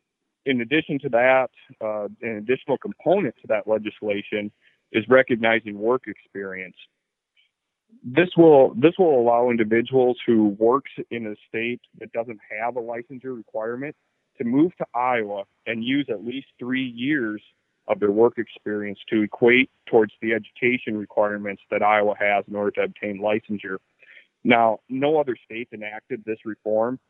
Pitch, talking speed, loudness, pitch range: 115 Hz, 150 wpm, -22 LUFS, 105-130 Hz